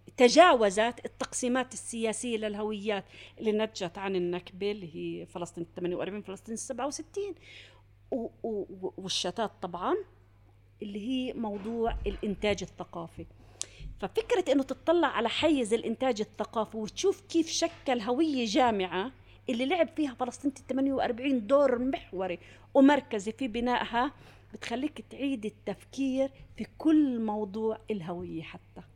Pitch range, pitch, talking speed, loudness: 195-265 Hz, 225 Hz, 110 wpm, -30 LUFS